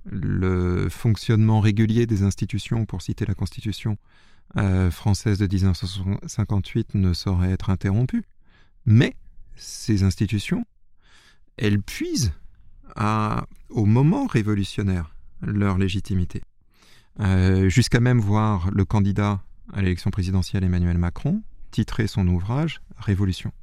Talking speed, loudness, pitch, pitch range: 110 wpm, -23 LUFS, 100 Hz, 95-110 Hz